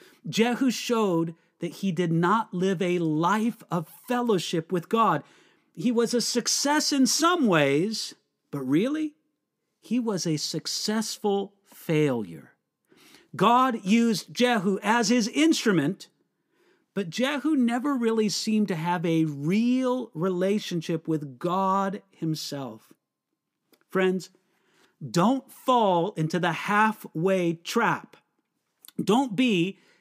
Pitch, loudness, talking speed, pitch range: 200 Hz, -25 LUFS, 110 wpm, 175-240 Hz